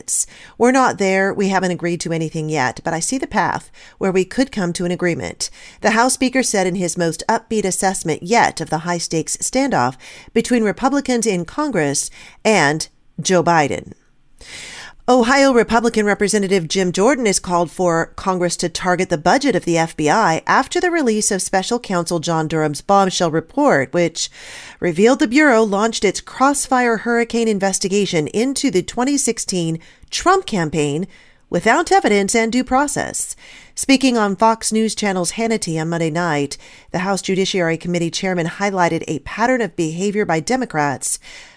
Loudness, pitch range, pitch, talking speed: -17 LUFS, 170-235 Hz, 195 Hz, 155 wpm